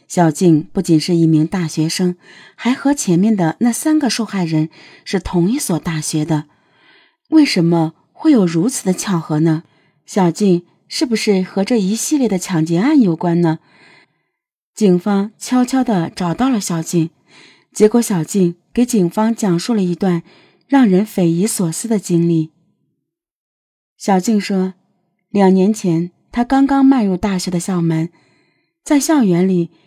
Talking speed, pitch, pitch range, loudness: 215 characters per minute, 190 Hz, 170-230 Hz, -16 LUFS